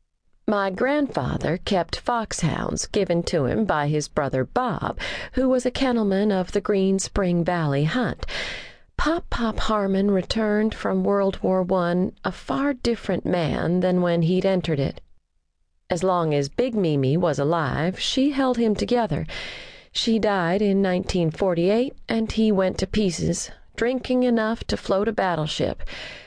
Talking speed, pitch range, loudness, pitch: 145 wpm, 170-225 Hz, -23 LUFS, 195 Hz